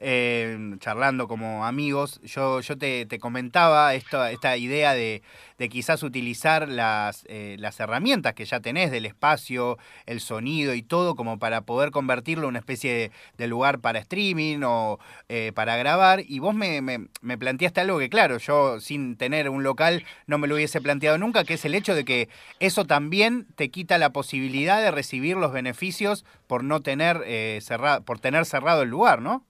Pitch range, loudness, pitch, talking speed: 120-155 Hz, -24 LUFS, 135 Hz, 185 wpm